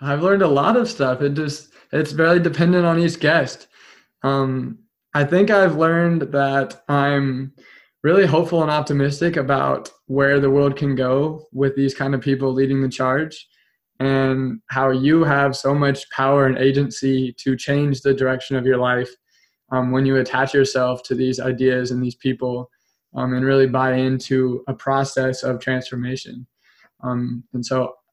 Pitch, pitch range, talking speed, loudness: 135 Hz, 130-145 Hz, 165 wpm, -19 LUFS